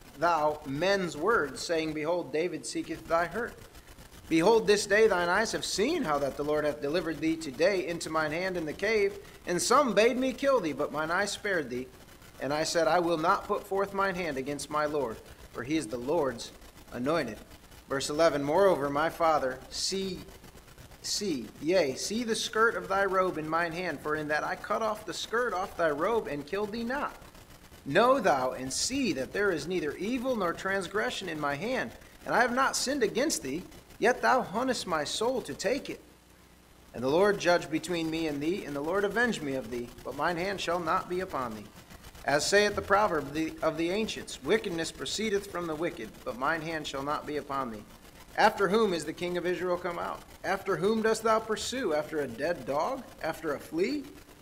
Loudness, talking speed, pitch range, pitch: -29 LUFS, 205 wpm, 150-205 Hz, 175 Hz